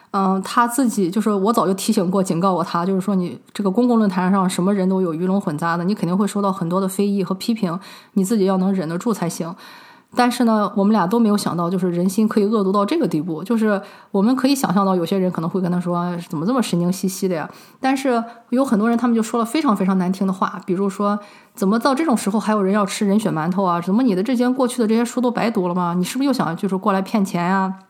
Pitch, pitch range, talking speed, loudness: 200 Hz, 185-225 Hz, 395 characters per minute, -19 LUFS